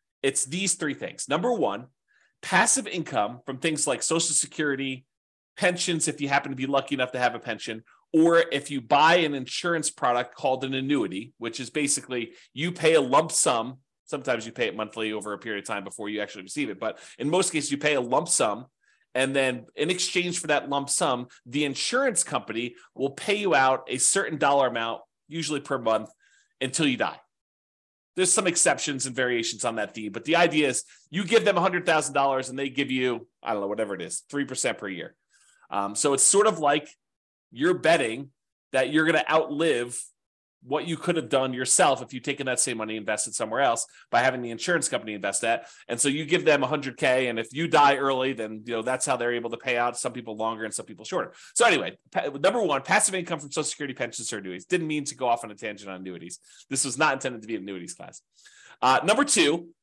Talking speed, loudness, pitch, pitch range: 220 wpm, -25 LUFS, 135 Hz, 120-160 Hz